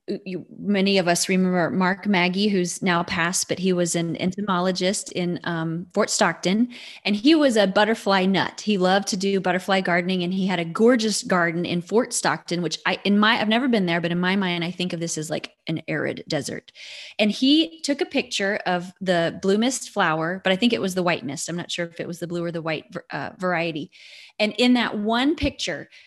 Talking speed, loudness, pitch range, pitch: 225 wpm, -22 LUFS, 175-210 Hz, 185 Hz